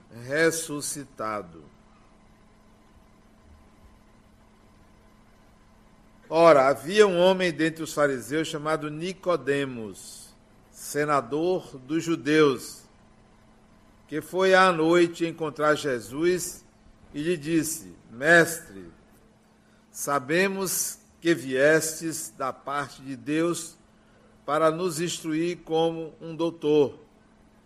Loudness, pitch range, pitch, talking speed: -25 LUFS, 135-165 Hz, 155 Hz, 80 wpm